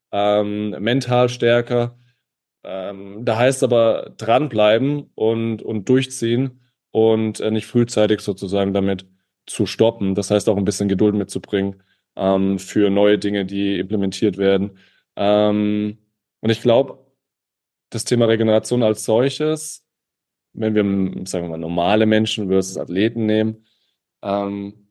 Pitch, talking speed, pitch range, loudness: 105 Hz, 130 wpm, 100-115 Hz, -19 LUFS